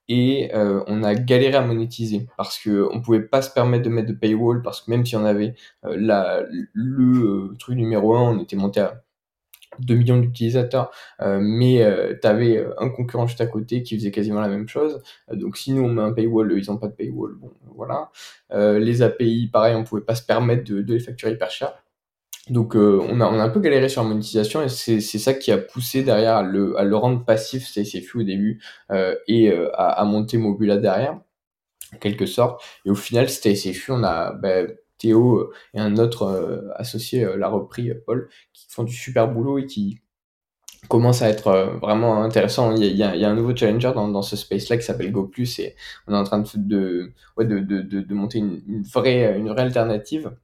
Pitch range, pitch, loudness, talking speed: 105-120 Hz, 110 Hz, -21 LUFS, 225 wpm